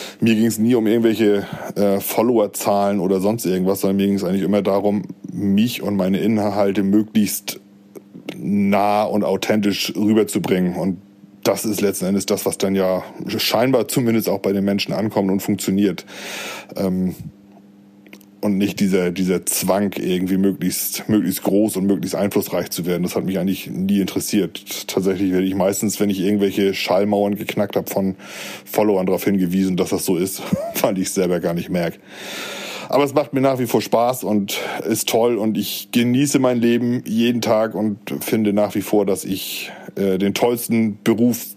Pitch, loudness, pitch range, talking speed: 100 Hz, -19 LUFS, 95-110 Hz, 175 wpm